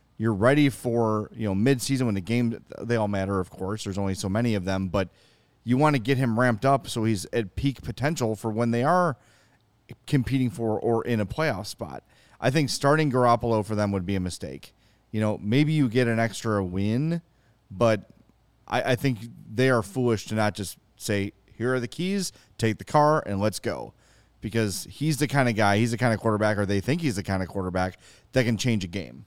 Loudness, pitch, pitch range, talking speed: -25 LUFS, 115 Hz, 100-130 Hz, 220 wpm